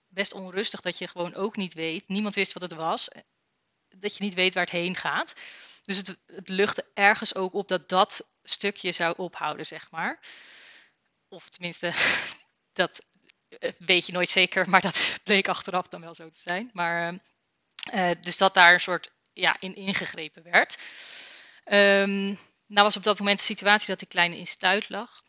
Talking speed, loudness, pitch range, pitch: 180 wpm, -24 LUFS, 175-200 Hz, 190 Hz